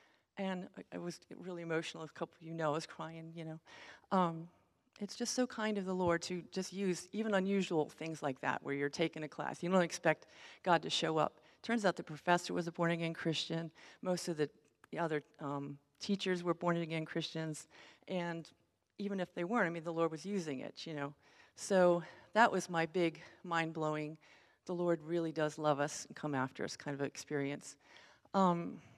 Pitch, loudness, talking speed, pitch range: 170 Hz, -38 LUFS, 200 wpm, 155-185 Hz